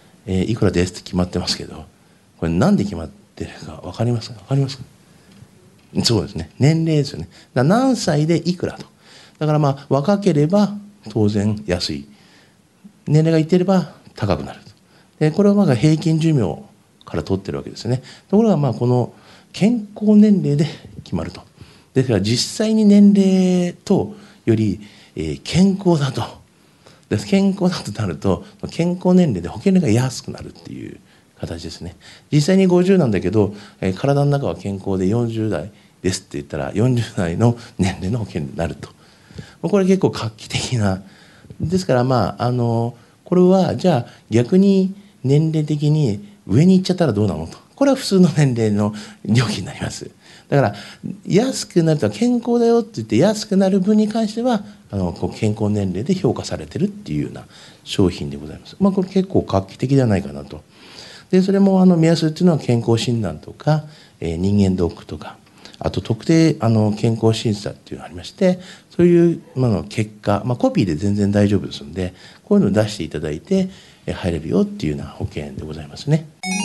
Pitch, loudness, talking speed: 135 Hz, -18 LUFS, 340 characters per minute